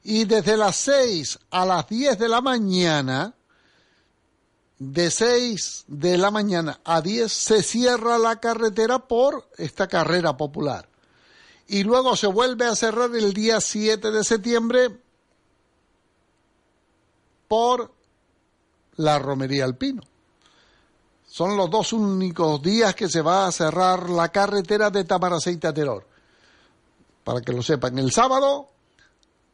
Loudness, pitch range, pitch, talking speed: -21 LUFS, 170-230 Hz, 205 Hz, 125 wpm